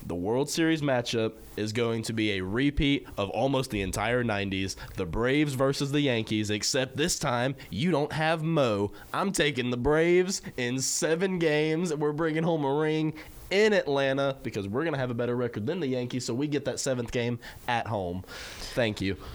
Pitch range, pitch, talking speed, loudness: 115-155 Hz, 130 Hz, 190 wpm, -28 LUFS